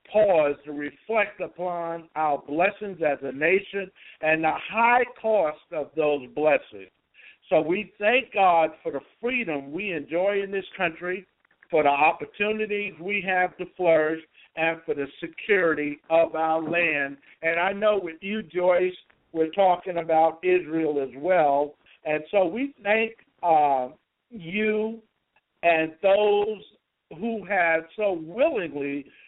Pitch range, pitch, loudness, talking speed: 155-205 Hz, 175 Hz, -25 LUFS, 135 wpm